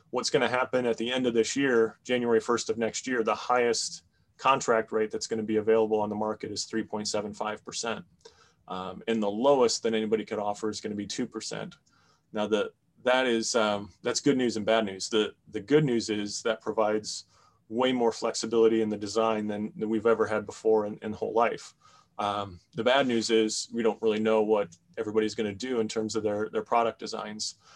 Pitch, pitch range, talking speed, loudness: 110 Hz, 105-115 Hz, 200 wpm, -28 LUFS